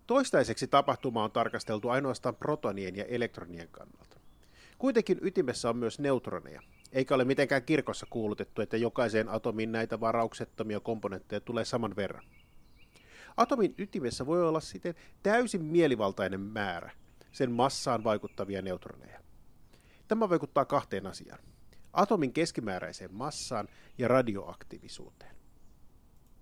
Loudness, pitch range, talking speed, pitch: -32 LUFS, 110-145 Hz, 110 wpm, 120 Hz